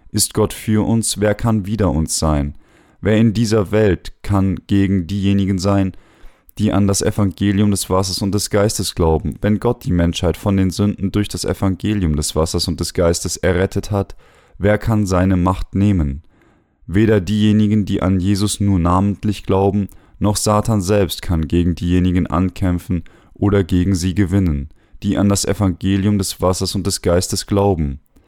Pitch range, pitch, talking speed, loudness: 90-105 Hz, 100 Hz, 165 wpm, -17 LUFS